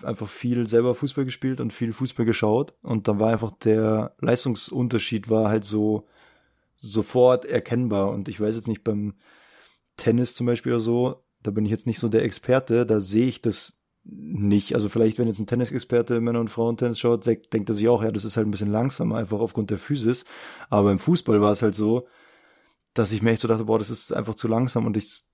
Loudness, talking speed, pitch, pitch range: -24 LUFS, 215 wpm, 115 Hz, 110-120 Hz